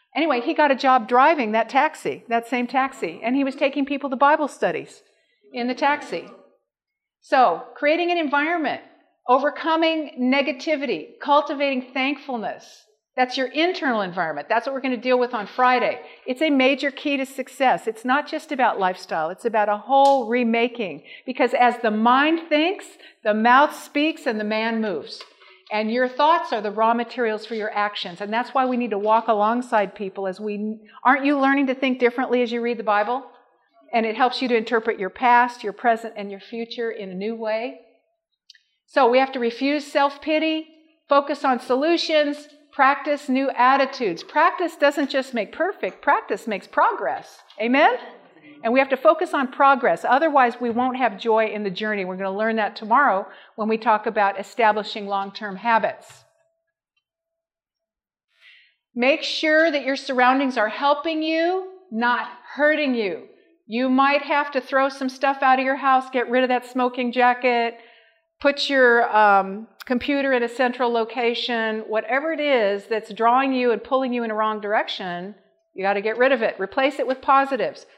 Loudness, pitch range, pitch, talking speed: -21 LUFS, 225-290 Hz, 255 Hz, 175 wpm